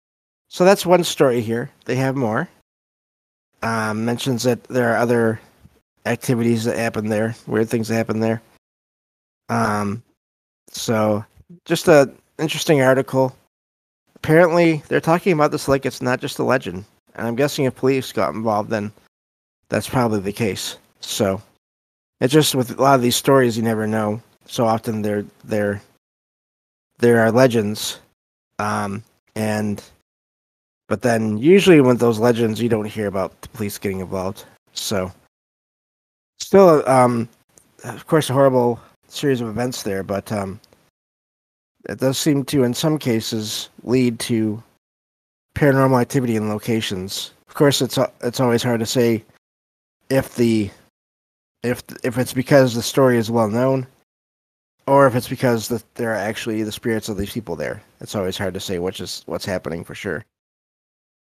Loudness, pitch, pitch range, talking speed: -19 LUFS, 115 Hz, 105-130 Hz, 155 wpm